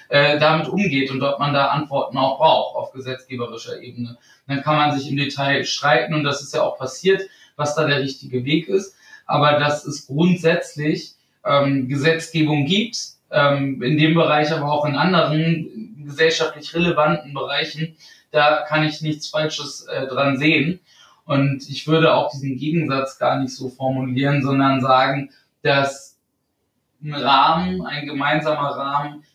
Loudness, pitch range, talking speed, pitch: -19 LUFS, 140-155 Hz, 145 wpm, 145 Hz